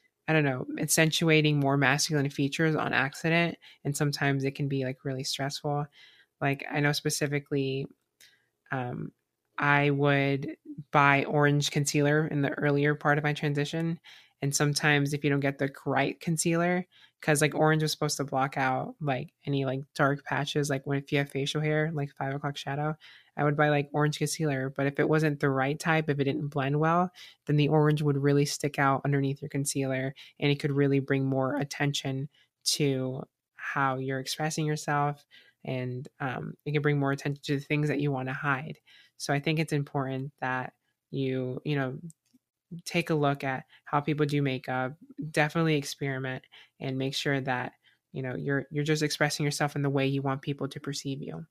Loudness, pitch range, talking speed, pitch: -28 LUFS, 135-150 Hz, 190 wpm, 145 Hz